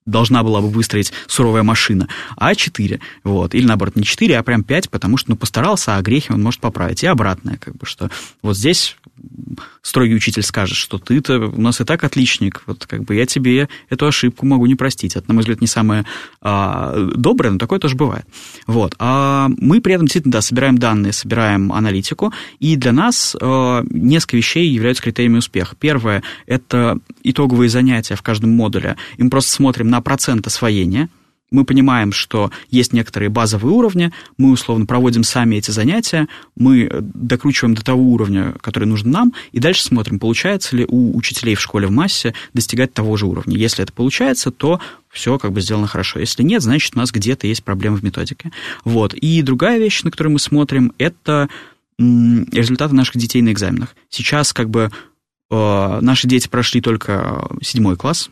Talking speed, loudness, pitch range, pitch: 180 wpm, -15 LUFS, 110-135 Hz, 120 Hz